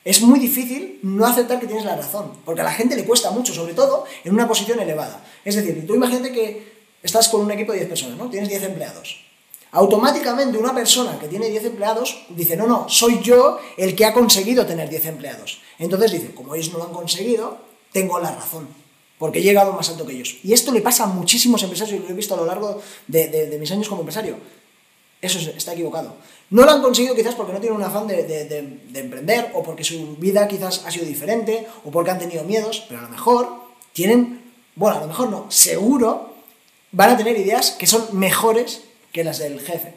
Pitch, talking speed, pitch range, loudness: 210 Hz, 225 wpm, 170-235 Hz, -18 LUFS